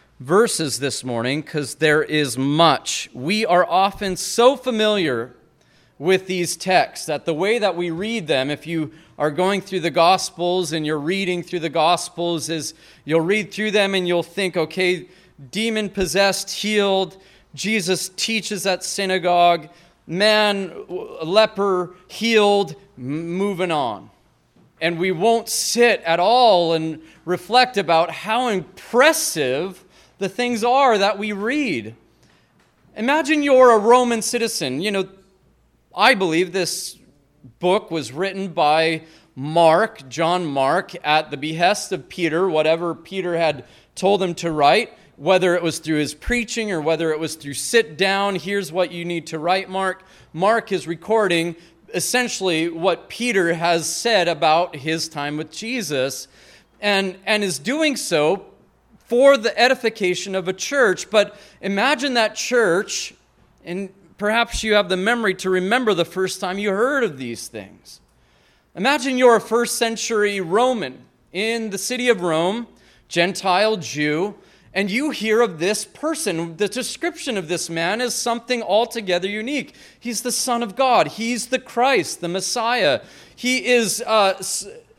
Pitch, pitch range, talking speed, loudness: 190 Hz, 165-220 Hz, 145 wpm, -20 LUFS